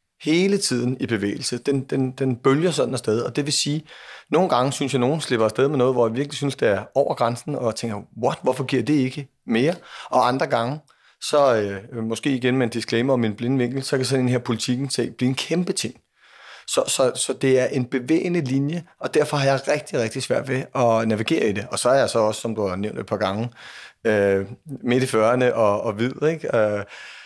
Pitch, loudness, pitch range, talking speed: 130 Hz, -22 LUFS, 115-140 Hz, 230 wpm